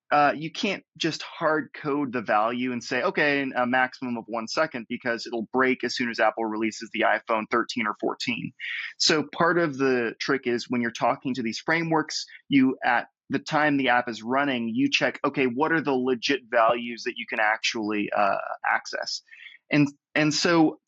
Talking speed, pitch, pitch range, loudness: 190 wpm, 130 Hz, 120-155 Hz, -25 LUFS